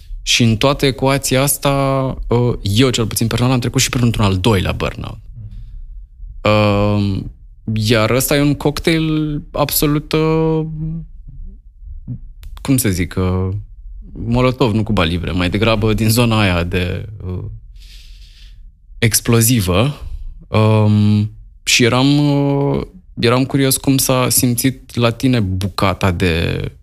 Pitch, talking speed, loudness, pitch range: 110 Hz, 105 wpm, -15 LUFS, 95-130 Hz